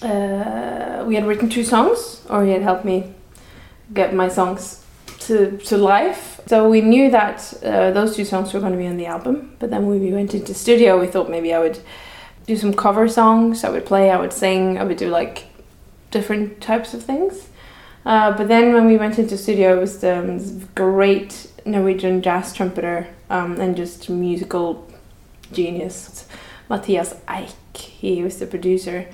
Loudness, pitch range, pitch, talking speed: -18 LUFS, 180-215 Hz, 195 Hz, 180 wpm